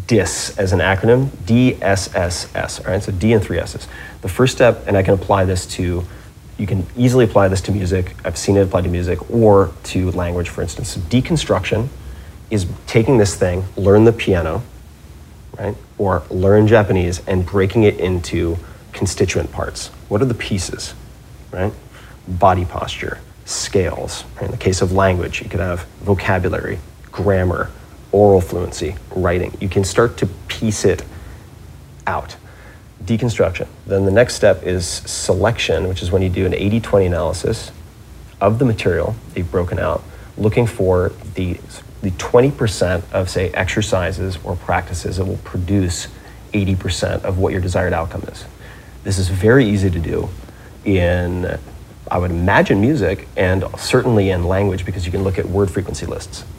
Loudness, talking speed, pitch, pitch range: -17 LUFS, 160 wpm, 95 Hz, 90-105 Hz